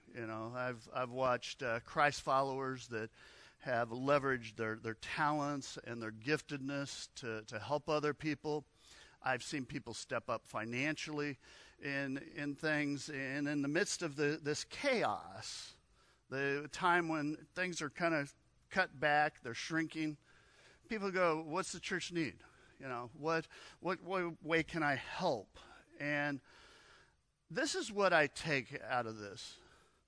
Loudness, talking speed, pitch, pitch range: -38 LUFS, 150 wpm, 145 Hz, 125-160 Hz